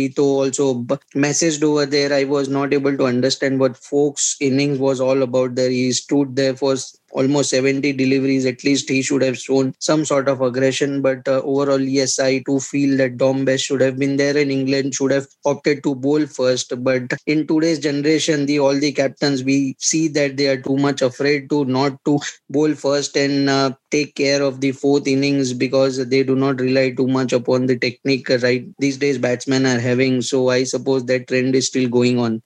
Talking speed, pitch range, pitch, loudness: 200 wpm, 130-140 Hz, 135 Hz, -18 LUFS